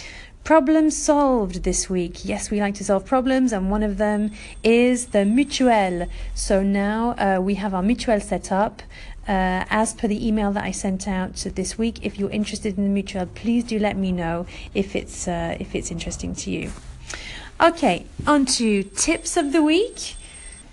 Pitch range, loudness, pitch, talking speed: 195-240 Hz, -22 LUFS, 210 Hz, 180 wpm